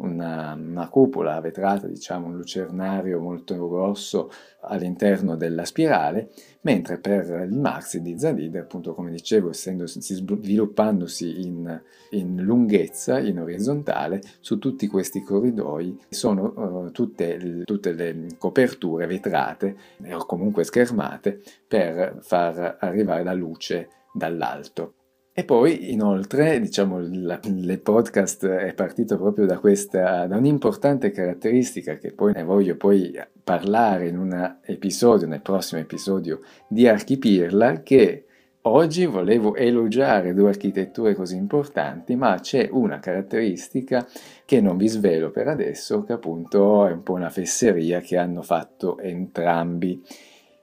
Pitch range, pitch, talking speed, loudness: 85-105 Hz, 95 Hz, 125 wpm, -22 LUFS